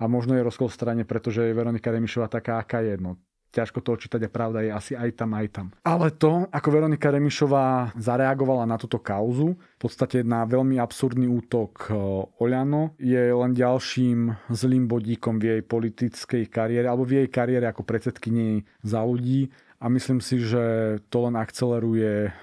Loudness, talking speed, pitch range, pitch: -25 LUFS, 175 wpm, 115-130 Hz, 120 Hz